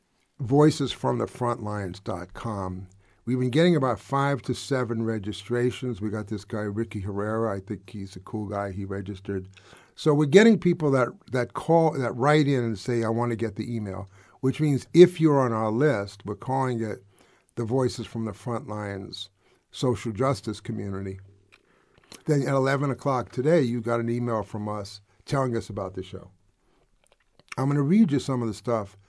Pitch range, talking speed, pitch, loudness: 100-130 Hz, 175 wpm, 115 Hz, -26 LUFS